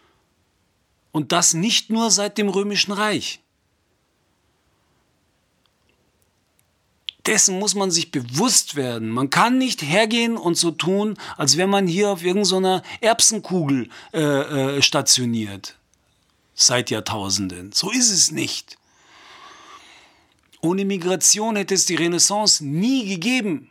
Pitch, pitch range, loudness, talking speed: 185 Hz, 150-215 Hz, -18 LUFS, 115 wpm